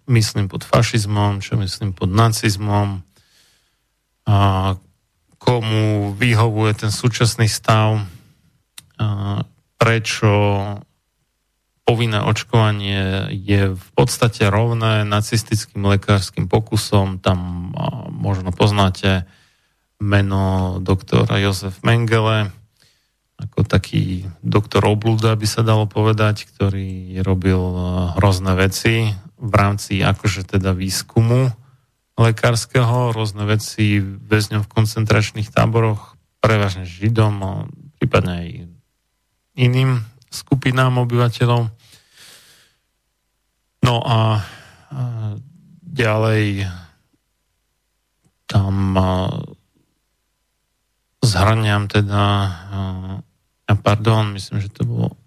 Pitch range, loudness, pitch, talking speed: 95-115 Hz, -18 LUFS, 105 Hz, 80 wpm